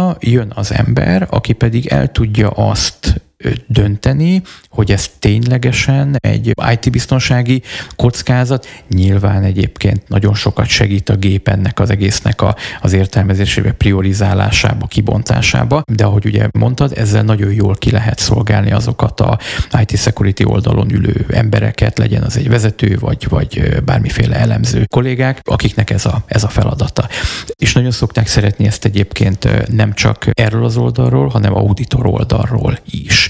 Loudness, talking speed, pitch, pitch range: -13 LUFS, 140 wpm, 110 Hz, 105-125 Hz